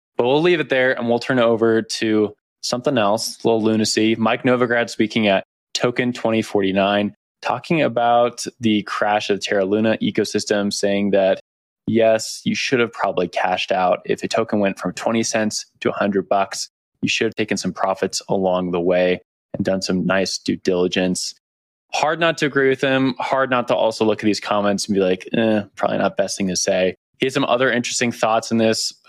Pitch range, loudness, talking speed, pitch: 100-120 Hz, -19 LUFS, 200 wpm, 110 Hz